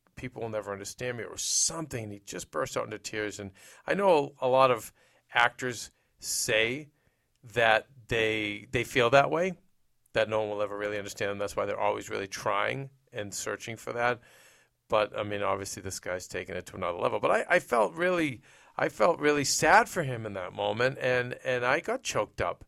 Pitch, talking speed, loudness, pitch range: 120 Hz, 200 wpm, -29 LUFS, 105-130 Hz